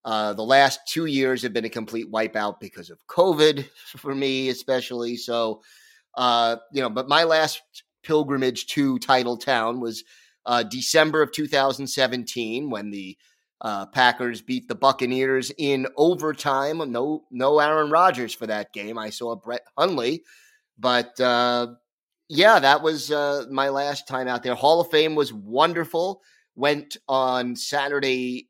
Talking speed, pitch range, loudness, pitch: 150 wpm, 120-145 Hz, -22 LUFS, 130 Hz